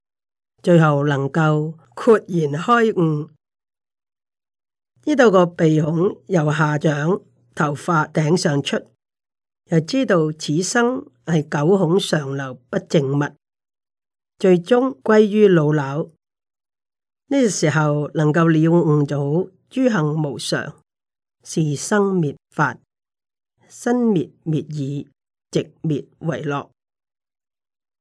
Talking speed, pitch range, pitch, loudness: 140 characters per minute, 150-190 Hz, 160 Hz, -19 LUFS